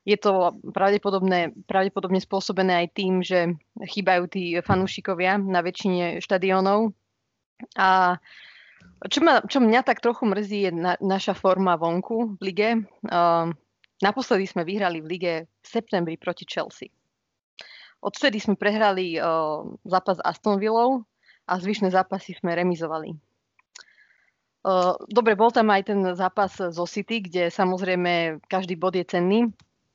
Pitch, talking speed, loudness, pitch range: 190 Hz, 135 wpm, -23 LUFS, 180-205 Hz